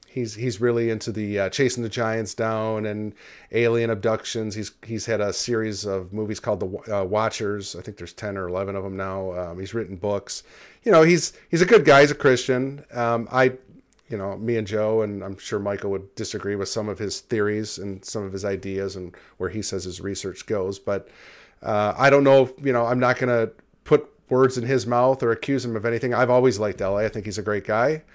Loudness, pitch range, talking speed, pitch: -23 LUFS, 100-125 Hz, 230 wpm, 110 Hz